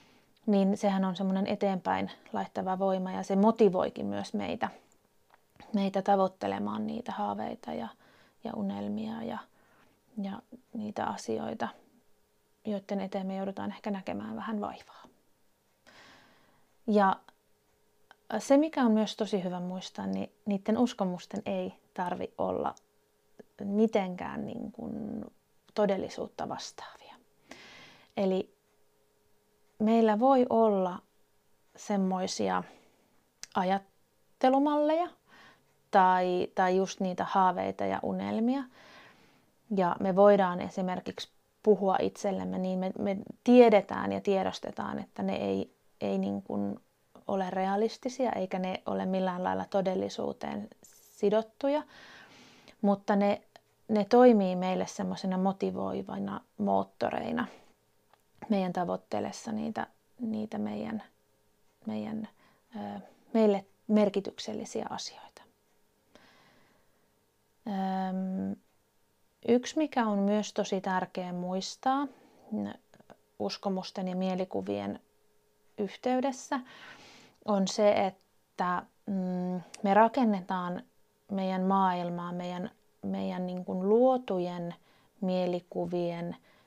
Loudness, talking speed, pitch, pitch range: -31 LUFS, 90 wpm, 195 Hz, 180-215 Hz